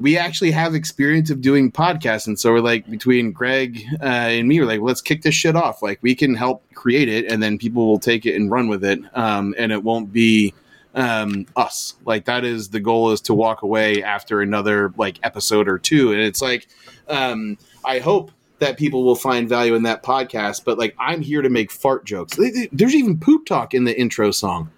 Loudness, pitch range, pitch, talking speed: -18 LUFS, 105-135 Hz, 115 Hz, 225 wpm